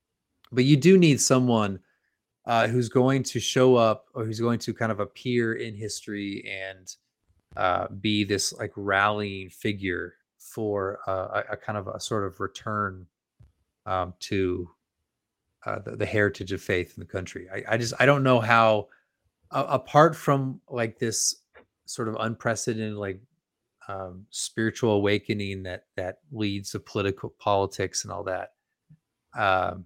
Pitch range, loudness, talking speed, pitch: 100-120 Hz, -26 LUFS, 155 wpm, 110 Hz